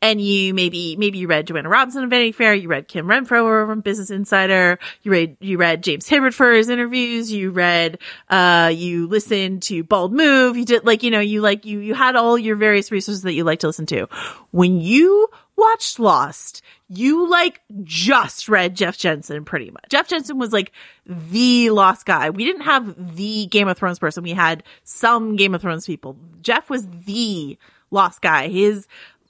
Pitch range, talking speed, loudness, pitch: 175-235 Hz, 195 wpm, -17 LUFS, 205 Hz